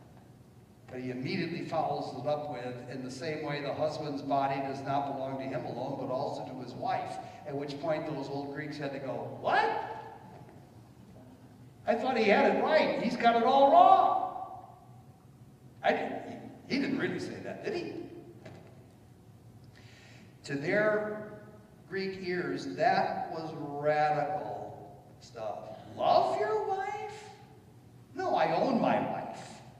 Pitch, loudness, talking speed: 150 Hz, -31 LUFS, 145 wpm